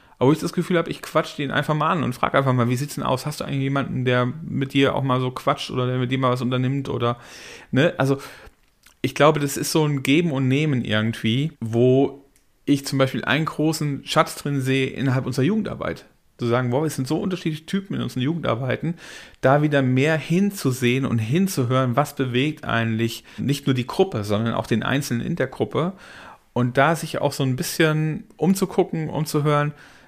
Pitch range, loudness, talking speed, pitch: 125-155 Hz, -22 LUFS, 205 wpm, 140 Hz